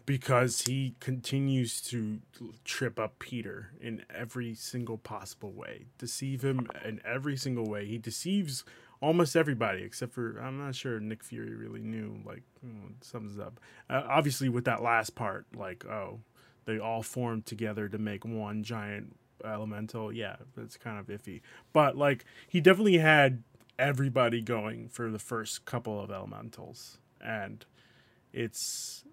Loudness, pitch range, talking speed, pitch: -32 LUFS, 110-130 Hz, 150 wpm, 115 Hz